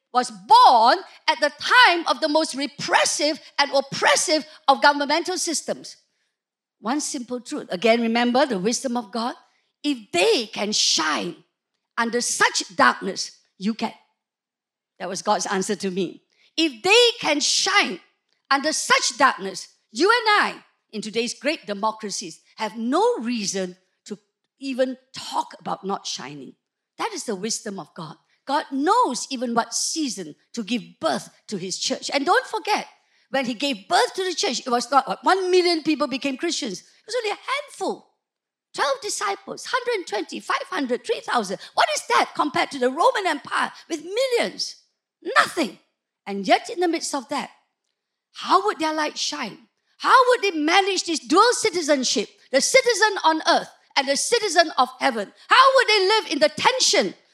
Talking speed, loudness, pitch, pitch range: 160 wpm, -21 LUFS, 295 Hz, 235-375 Hz